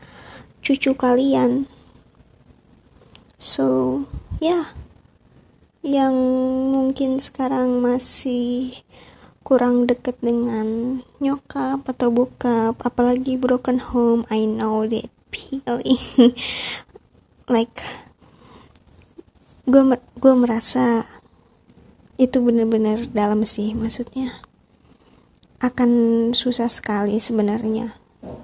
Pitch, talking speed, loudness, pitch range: 245 Hz, 75 wpm, -19 LUFS, 230-260 Hz